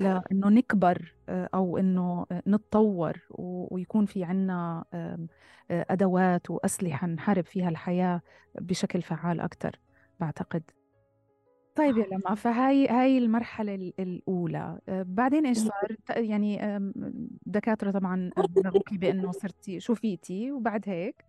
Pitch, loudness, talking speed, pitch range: 190 Hz, -28 LUFS, 100 wpm, 180-215 Hz